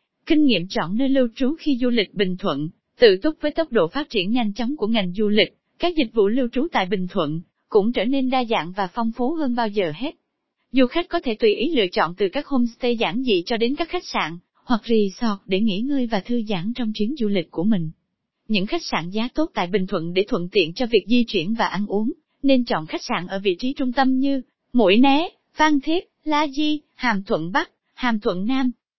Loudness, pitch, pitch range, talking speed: -22 LUFS, 240 Hz, 210-275 Hz, 240 wpm